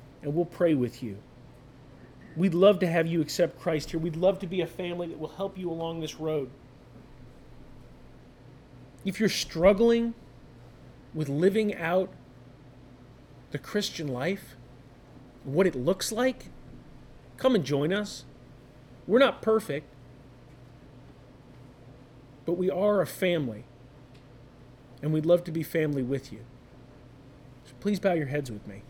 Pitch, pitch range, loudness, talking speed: 145 Hz, 125-180 Hz, -28 LUFS, 135 wpm